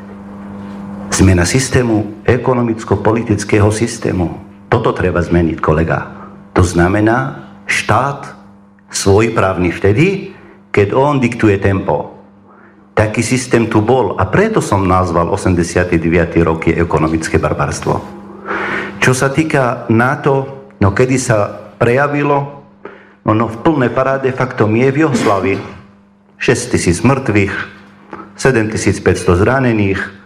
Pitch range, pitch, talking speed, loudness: 95-120 Hz, 105 Hz, 105 wpm, -14 LUFS